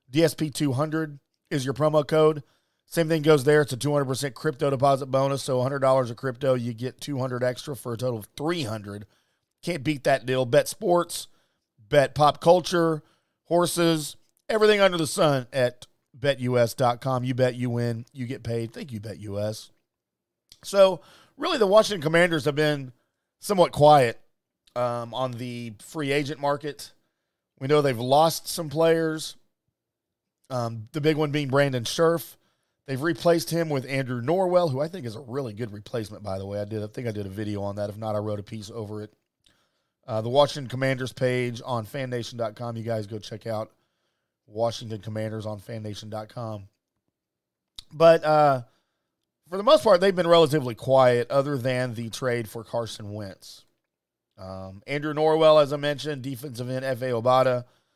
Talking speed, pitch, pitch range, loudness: 165 wpm, 130 Hz, 115-155 Hz, -24 LUFS